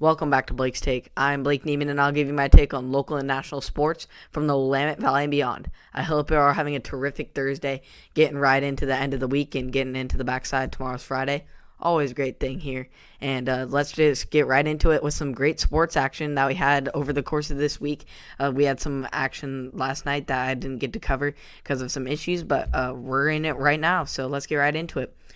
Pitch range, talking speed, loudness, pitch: 135-145 Hz, 250 wpm, -24 LUFS, 140 Hz